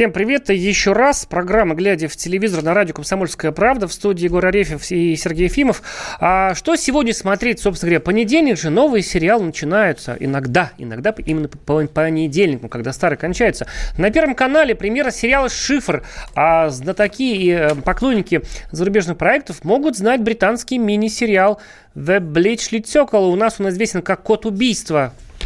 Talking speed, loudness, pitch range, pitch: 155 wpm, -17 LUFS, 165-225 Hz, 195 Hz